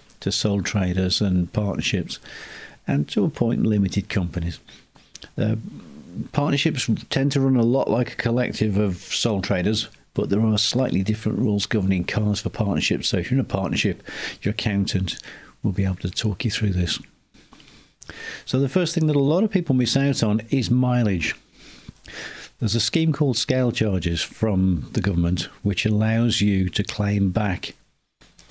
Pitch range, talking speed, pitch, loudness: 95-125 Hz, 165 wpm, 105 Hz, -22 LUFS